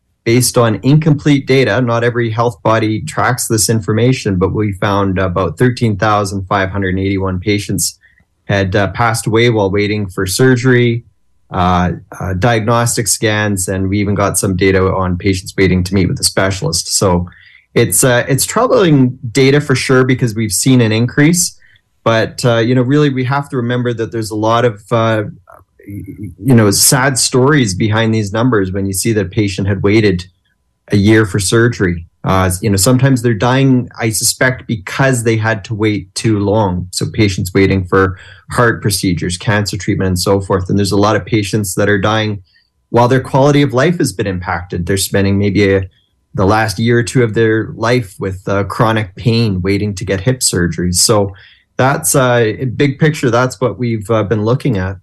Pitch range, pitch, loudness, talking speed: 100-120 Hz, 110 Hz, -13 LUFS, 185 wpm